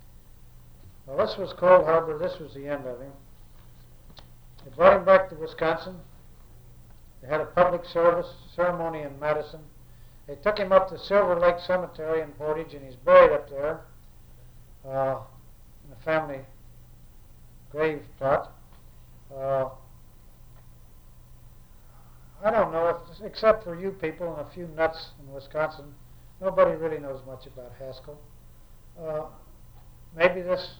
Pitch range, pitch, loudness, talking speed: 120-170 Hz, 150 Hz, -25 LUFS, 140 wpm